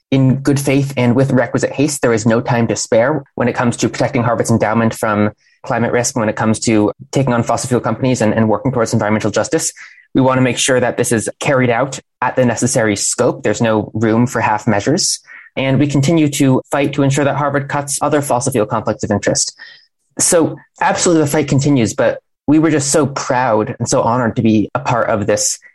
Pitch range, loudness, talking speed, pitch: 115-140 Hz, -15 LUFS, 220 wpm, 125 Hz